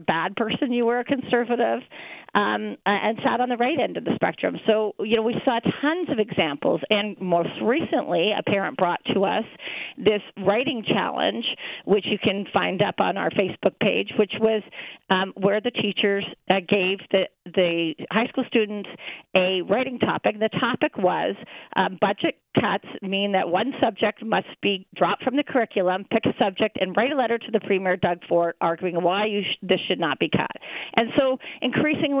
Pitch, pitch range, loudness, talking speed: 210 Hz, 185-240 Hz, -23 LUFS, 185 wpm